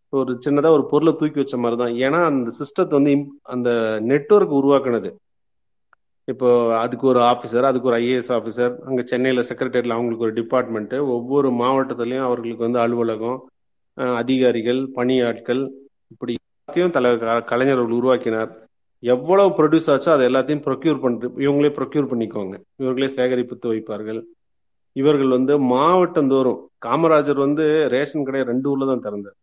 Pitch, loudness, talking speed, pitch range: 125 Hz, -19 LUFS, 130 wpm, 120-140 Hz